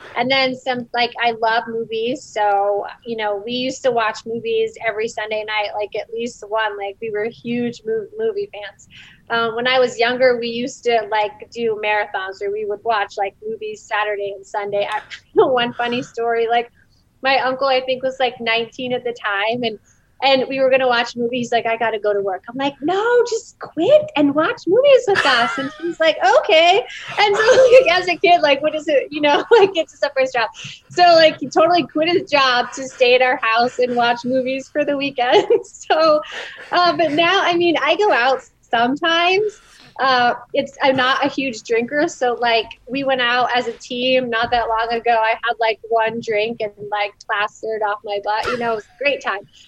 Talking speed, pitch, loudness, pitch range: 210 wpm, 245 Hz, -18 LUFS, 225-300 Hz